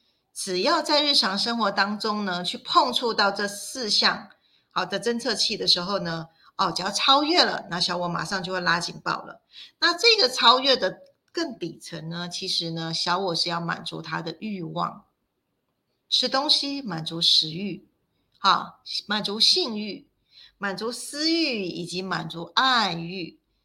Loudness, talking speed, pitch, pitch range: -23 LUFS, 225 characters per minute, 200 Hz, 175-240 Hz